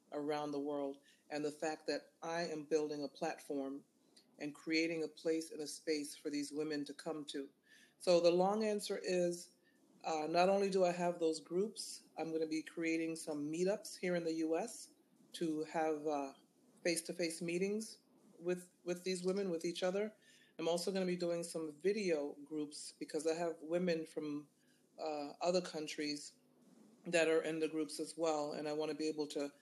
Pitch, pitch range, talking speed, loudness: 160 Hz, 155-180 Hz, 190 wpm, -40 LUFS